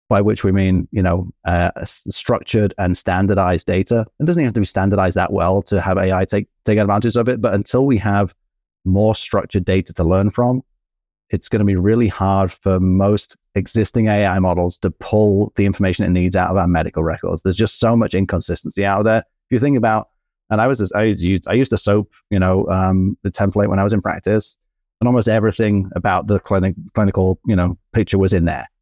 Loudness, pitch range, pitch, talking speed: -17 LUFS, 95-110 Hz, 100 Hz, 215 wpm